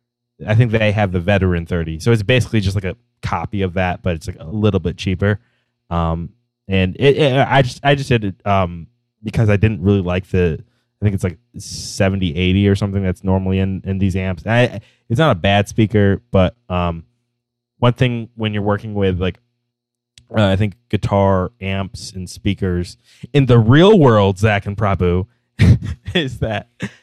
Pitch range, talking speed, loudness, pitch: 95-120 Hz, 185 wpm, -17 LUFS, 105 Hz